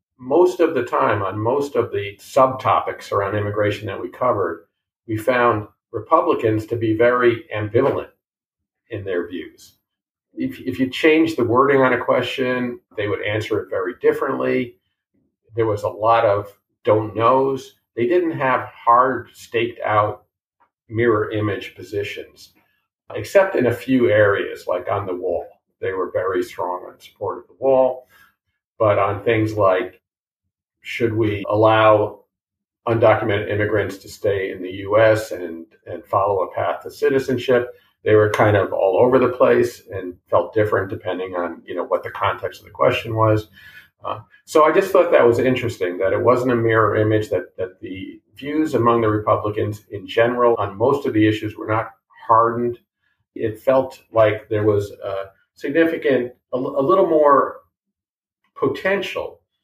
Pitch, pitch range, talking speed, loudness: 115 Hz, 105-135 Hz, 160 wpm, -19 LUFS